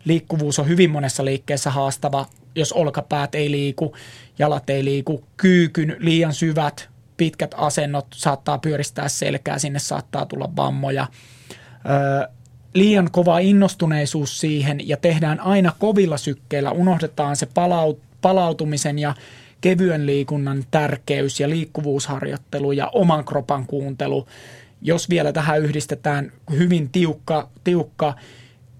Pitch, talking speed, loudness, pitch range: 145 Hz, 115 wpm, -20 LUFS, 140-160 Hz